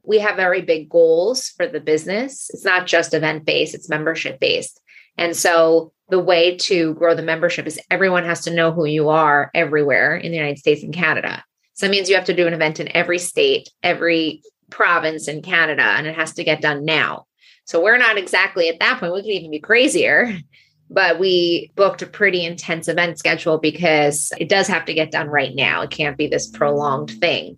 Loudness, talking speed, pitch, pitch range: -17 LUFS, 205 wpm, 170 Hz, 155-185 Hz